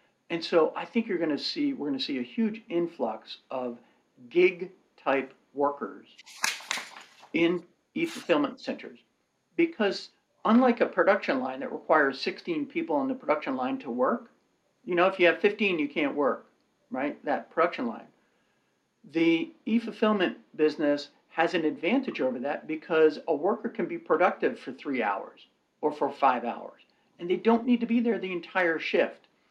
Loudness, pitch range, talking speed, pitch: -28 LUFS, 165-270 Hz, 170 wpm, 215 Hz